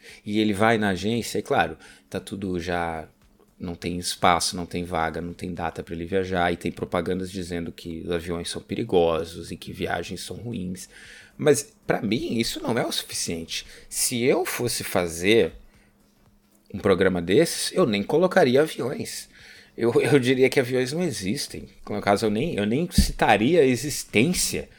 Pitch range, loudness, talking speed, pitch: 85-110 Hz, -24 LUFS, 170 wpm, 90 Hz